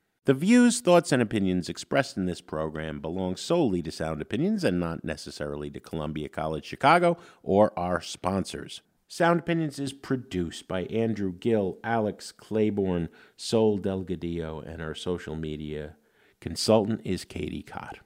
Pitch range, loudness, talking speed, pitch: 80-115 Hz, -27 LUFS, 145 wpm, 90 Hz